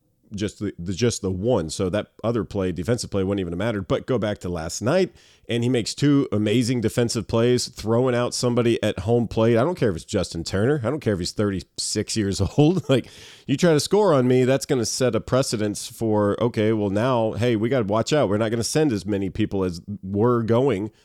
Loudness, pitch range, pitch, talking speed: -22 LUFS, 100-125 Hz, 115 Hz, 240 wpm